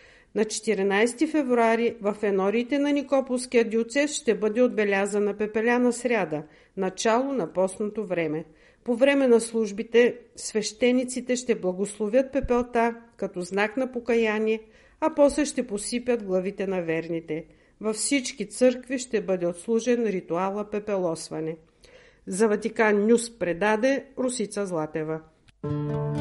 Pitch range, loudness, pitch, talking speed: 195-245 Hz, -25 LUFS, 220 Hz, 115 wpm